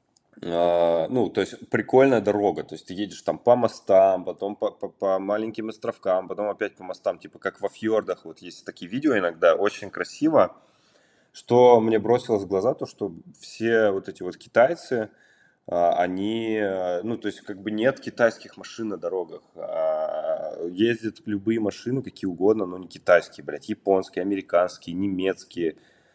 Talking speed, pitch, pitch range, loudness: 155 wpm, 105 Hz, 95-115 Hz, -24 LUFS